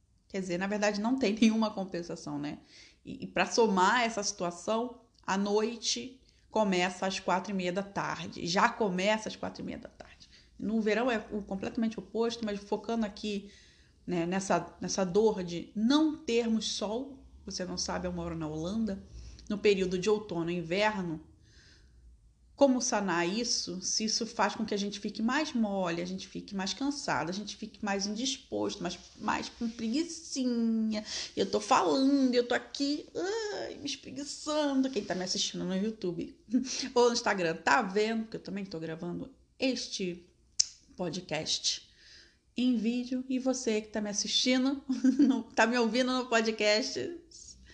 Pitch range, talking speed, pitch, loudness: 190-245 Hz, 165 wpm, 215 Hz, -31 LUFS